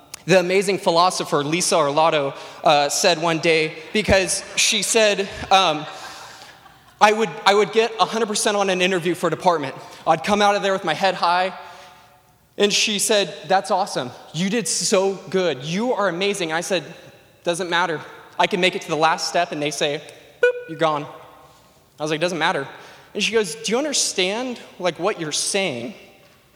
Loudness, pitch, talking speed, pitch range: -20 LUFS, 185 Hz, 175 wpm, 160-200 Hz